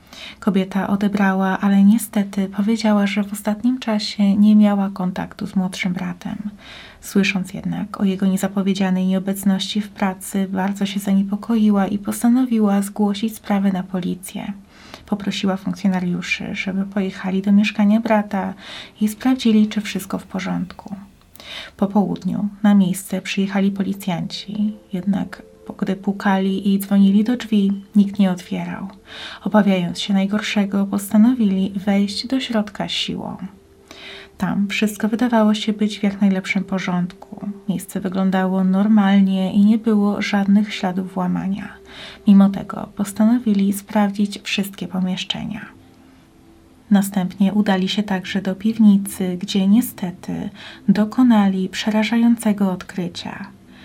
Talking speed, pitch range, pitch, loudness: 115 wpm, 195-210 Hz, 200 Hz, -19 LUFS